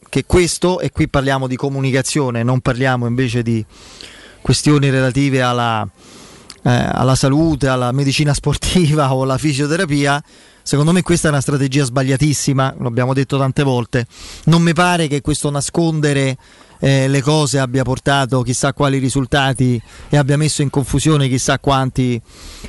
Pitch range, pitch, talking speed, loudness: 130-150 Hz, 140 Hz, 145 wpm, -16 LUFS